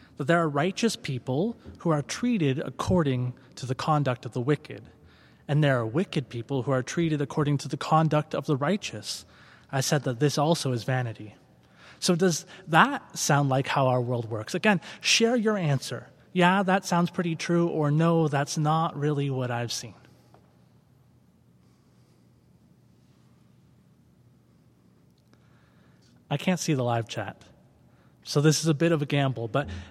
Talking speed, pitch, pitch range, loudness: 155 wpm, 145 Hz, 130-165 Hz, -26 LUFS